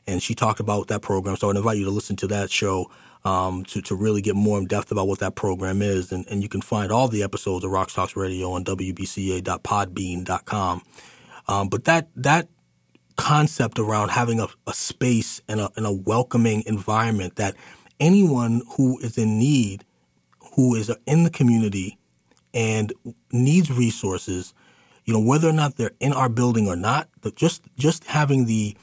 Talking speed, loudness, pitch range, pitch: 180 wpm, -23 LUFS, 95-125 Hz, 105 Hz